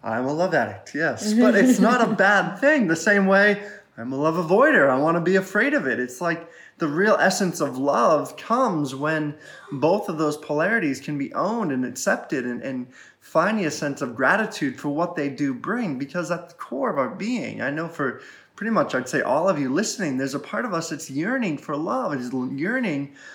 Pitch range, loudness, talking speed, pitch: 145-205 Hz, -22 LUFS, 215 wpm, 165 Hz